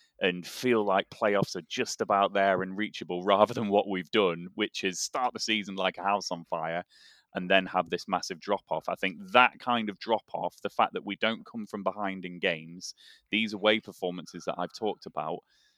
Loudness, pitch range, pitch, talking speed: -29 LUFS, 90-105 Hz, 100 Hz, 215 wpm